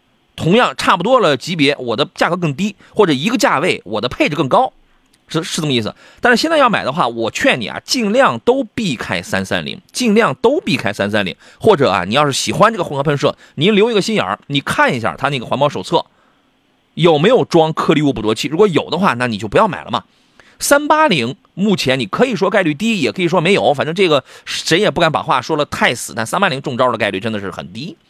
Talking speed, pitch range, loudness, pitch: 345 characters per minute, 145-220 Hz, -15 LUFS, 180 Hz